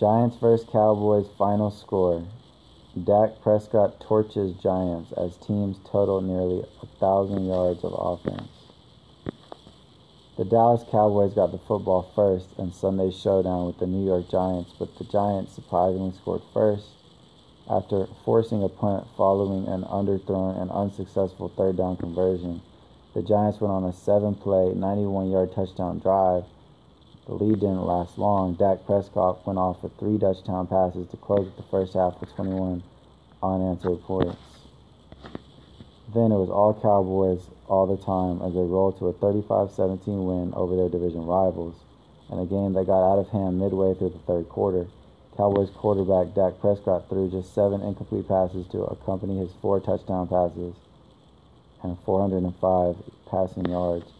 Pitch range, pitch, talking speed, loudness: 90-100 Hz, 95 Hz, 145 wpm, -25 LUFS